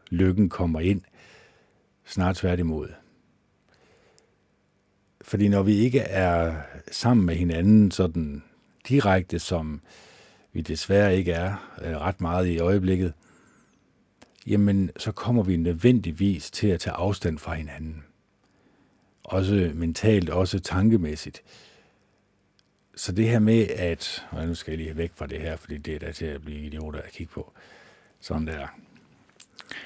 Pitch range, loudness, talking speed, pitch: 80-100 Hz, -25 LUFS, 135 wpm, 90 Hz